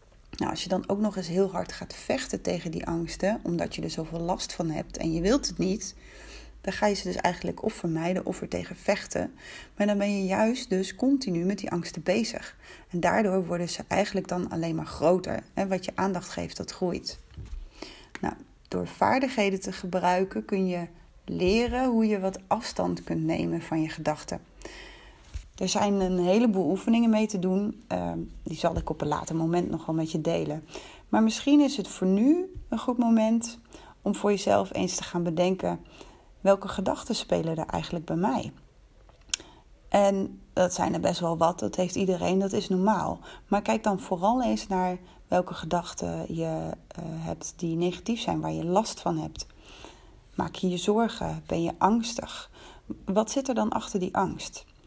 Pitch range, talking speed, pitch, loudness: 170-210 Hz, 185 wpm, 185 Hz, -28 LUFS